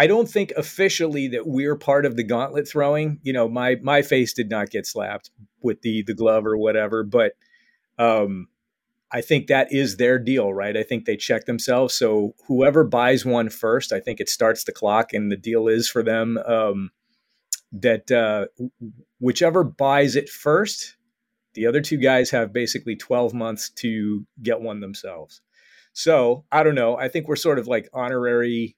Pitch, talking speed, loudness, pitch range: 125 Hz, 180 wpm, -21 LUFS, 115-145 Hz